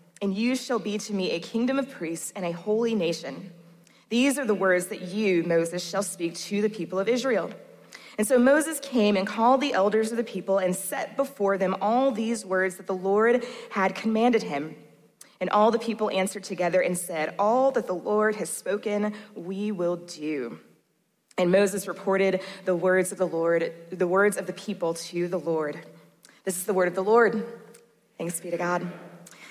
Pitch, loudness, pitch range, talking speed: 195 Hz, -26 LUFS, 175-215 Hz, 195 wpm